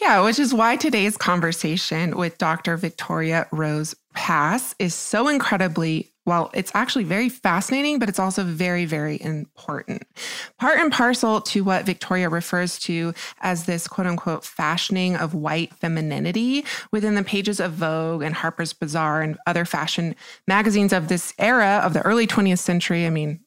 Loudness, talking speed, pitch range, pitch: -22 LUFS, 160 wpm, 165-210 Hz, 180 Hz